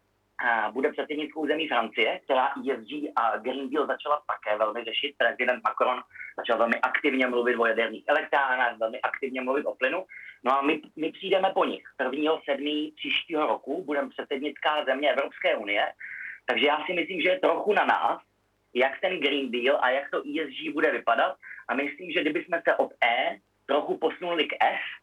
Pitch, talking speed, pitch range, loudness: 135 Hz, 175 wpm, 120-150 Hz, -27 LUFS